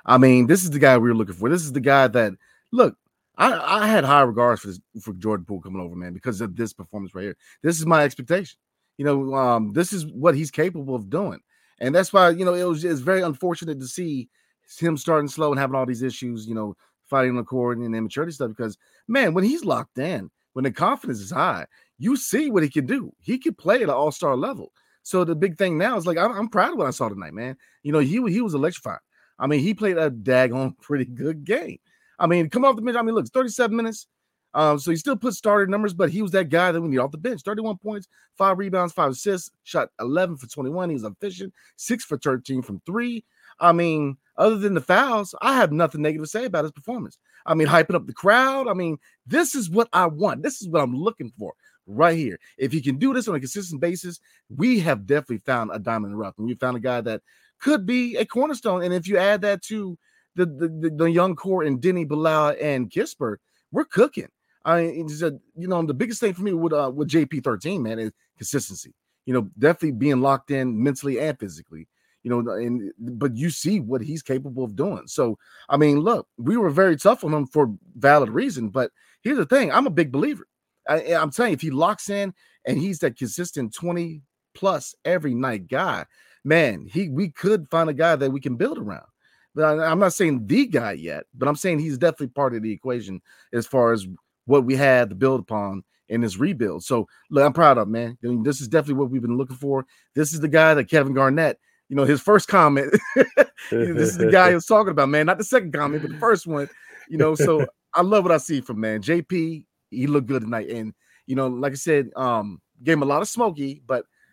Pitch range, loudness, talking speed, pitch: 130-185 Hz, -22 LUFS, 240 wpm, 155 Hz